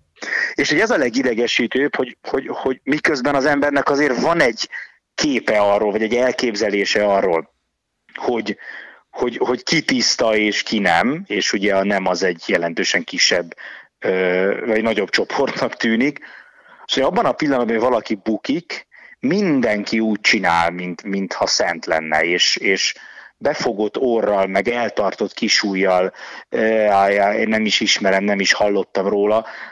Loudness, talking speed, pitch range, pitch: -18 LUFS, 140 wpm, 95-110 Hz, 100 Hz